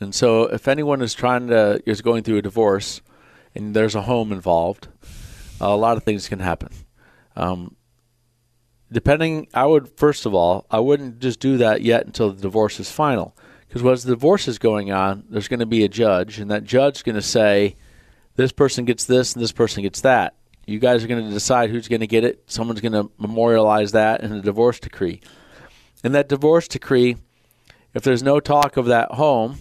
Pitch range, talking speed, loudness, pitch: 105-125 Hz, 205 wpm, -19 LUFS, 115 Hz